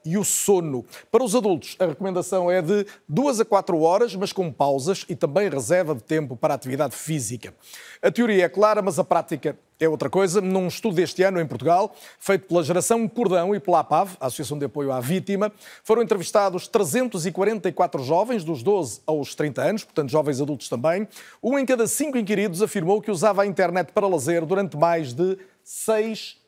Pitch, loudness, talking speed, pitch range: 185 Hz, -23 LUFS, 190 wpm, 160-205 Hz